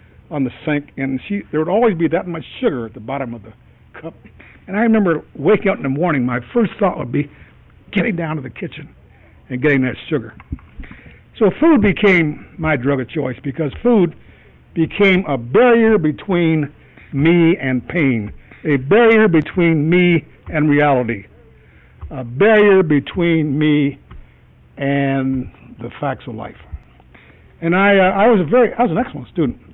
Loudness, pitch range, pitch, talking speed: -16 LUFS, 130-180 Hz, 150 Hz, 165 wpm